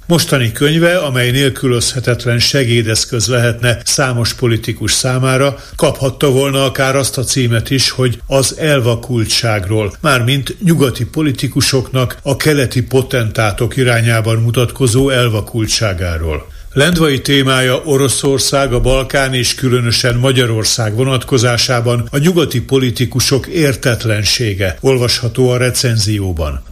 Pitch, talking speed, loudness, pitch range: 125 Hz, 100 wpm, -13 LUFS, 115-135 Hz